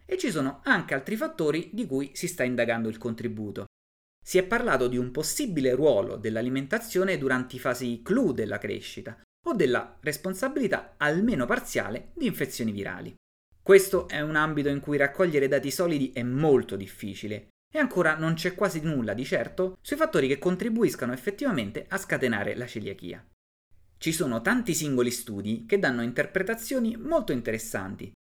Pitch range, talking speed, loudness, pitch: 115-190 Hz, 155 wpm, -27 LUFS, 140 Hz